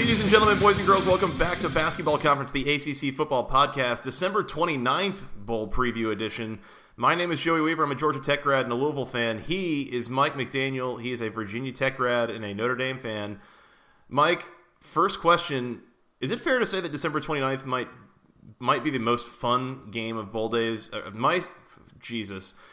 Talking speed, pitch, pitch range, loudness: 195 wpm, 135 Hz, 120-165 Hz, -26 LUFS